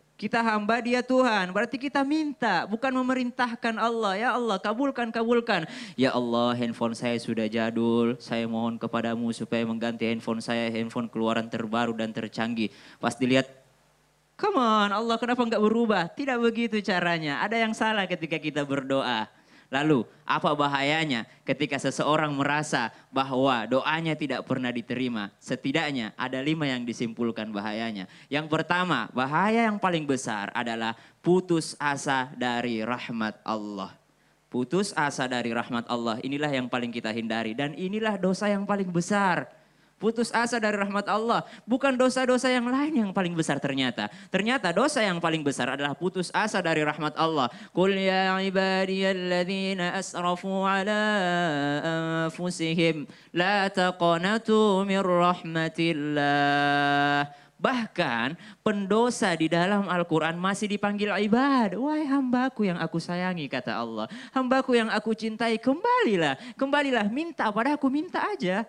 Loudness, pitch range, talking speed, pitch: -26 LUFS, 130-215 Hz, 130 wpm, 170 Hz